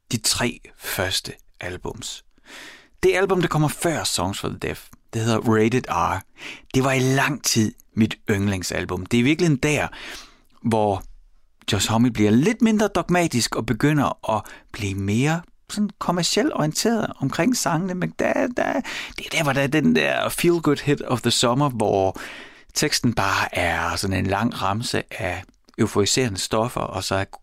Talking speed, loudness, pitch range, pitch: 170 wpm, -22 LUFS, 105-175 Hz, 130 Hz